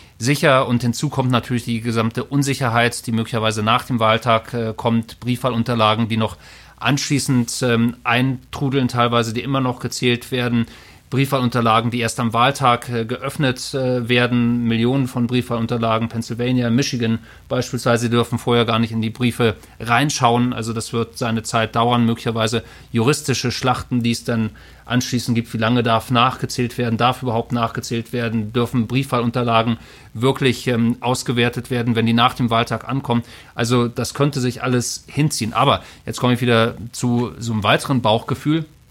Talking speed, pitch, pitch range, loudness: 155 wpm, 120 Hz, 115-125 Hz, -19 LUFS